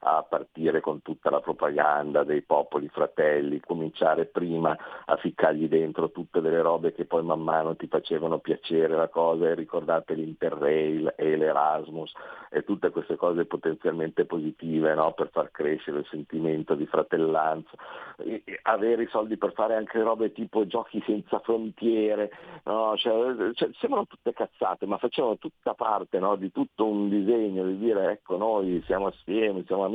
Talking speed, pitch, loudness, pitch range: 160 wpm, 95 Hz, -27 LUFS, 80-115 Hz